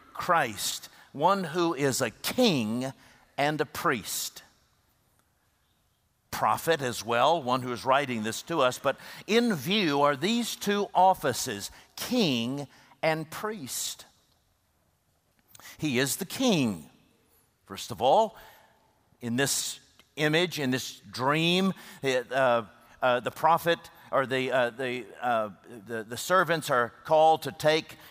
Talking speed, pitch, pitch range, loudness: 125 wpm, 145 Hz, 125-180 Hz, -27 LUFS